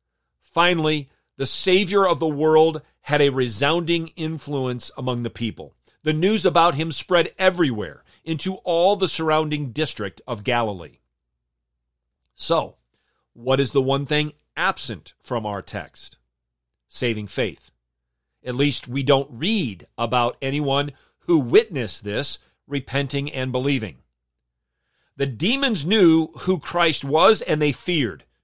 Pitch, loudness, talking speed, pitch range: 140 Hz, -21 LUFS, 125 wpm, 110-160 Hz